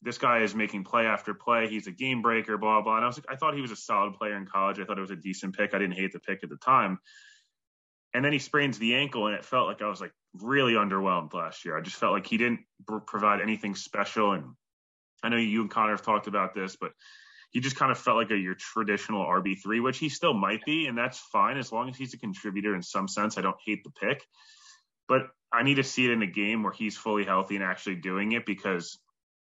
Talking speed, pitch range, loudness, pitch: 265 wpm, 100-120 Hz, -28 LUFS, 110 Hz